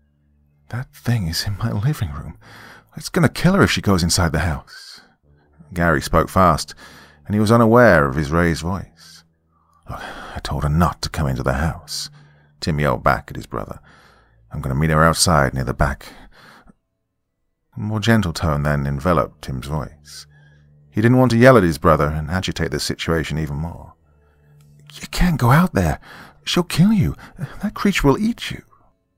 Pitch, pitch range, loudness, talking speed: 80 Hz, 75-105 Hz, -18 LUFS, 185 wpm